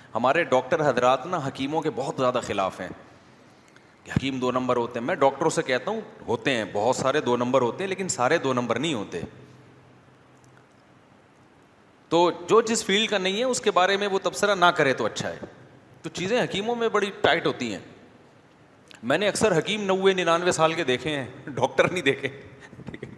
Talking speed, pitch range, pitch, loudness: 190 wpm, 130-195 Hz, 165 Hz, -24 LUFS